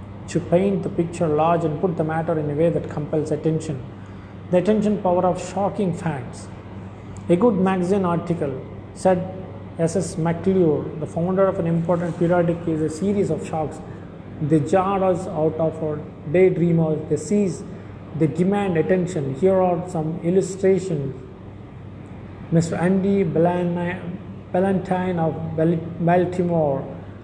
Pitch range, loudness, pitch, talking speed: 150-185 Hz, -21 LUFS, 165 Hz, 130 wpm